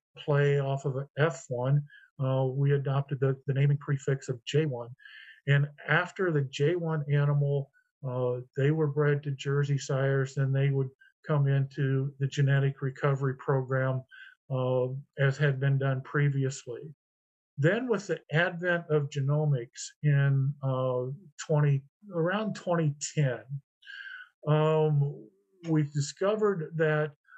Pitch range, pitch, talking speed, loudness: 135-155 Hz, 140 Hz, 125 wpm, -29 LUFS